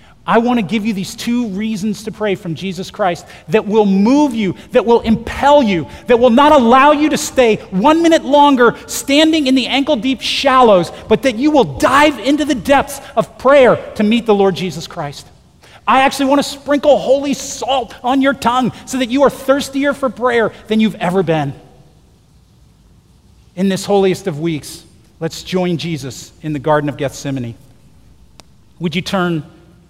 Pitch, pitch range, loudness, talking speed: 225 Hz, 180-270 Hz, -14 LUFS, 180 wpm